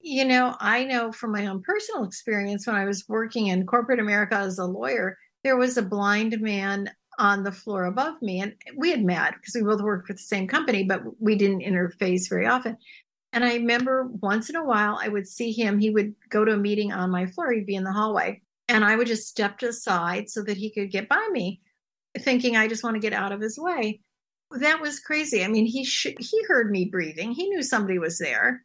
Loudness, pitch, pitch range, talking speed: -25 LUFS, 215 Hz, 200-245 Hz, 235 wpm